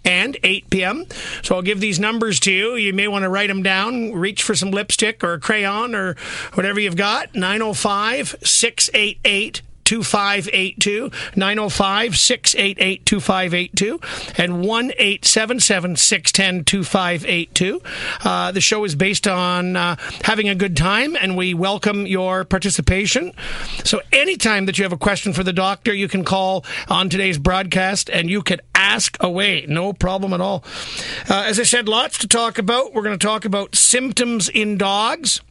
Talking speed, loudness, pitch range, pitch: 160 wpm, -17 LUFS, 185-215 Hz, 195 Hz